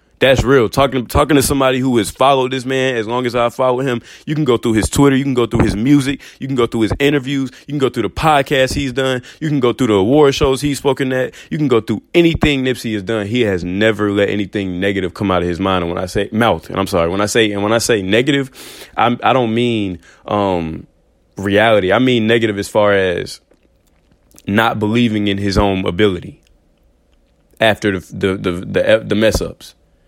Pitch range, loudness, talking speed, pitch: 100-130 Hz, -15 LUFS, 225 wpm, 115 Hz